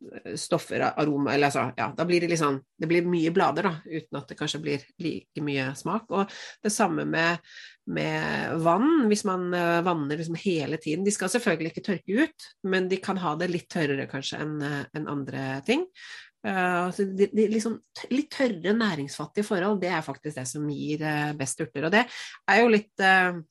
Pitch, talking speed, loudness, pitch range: 170 Hz, 195 wpm, -26 LUFS, 150-200 Hz